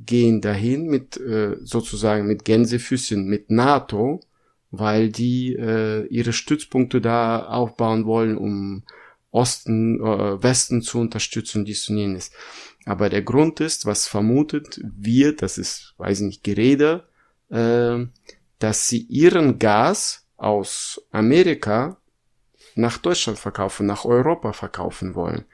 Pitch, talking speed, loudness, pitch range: 115 Hz, 115 wpm, -21 LUFS, 105-120 Hz